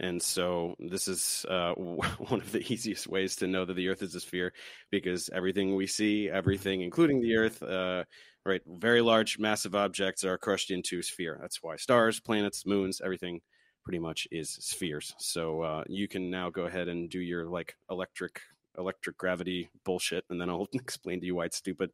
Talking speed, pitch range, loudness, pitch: 195 wpm, 90-100 Hz, -32 LUFS, 95 Hz